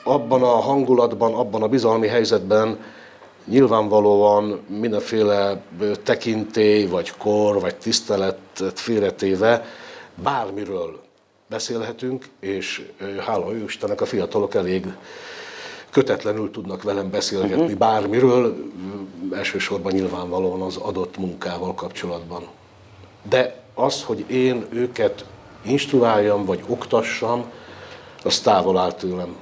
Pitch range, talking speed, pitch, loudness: 95-125 Hz, 95 wpm, 105 Hz, -21 LUFS